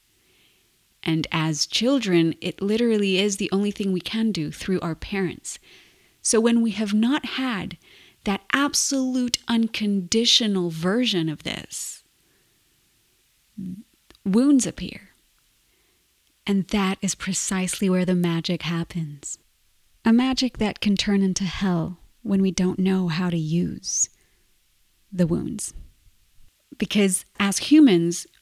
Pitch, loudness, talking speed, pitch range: 195 Hz, -23 LUFS, 120 wpm, 180-225 Hz